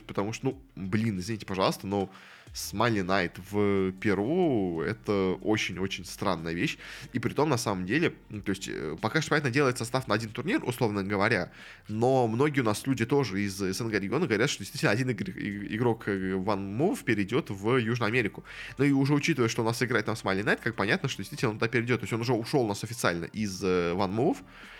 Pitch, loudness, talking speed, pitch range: 110 Hz, -29 LUFS, 200 wpm, 100-125 Hz